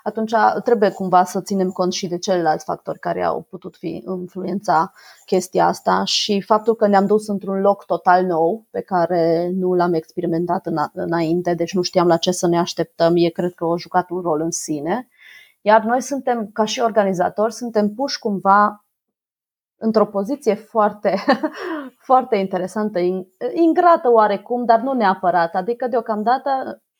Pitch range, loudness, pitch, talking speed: 175-225 Hz, -19 LUFS, 195 Hz, 160 wpm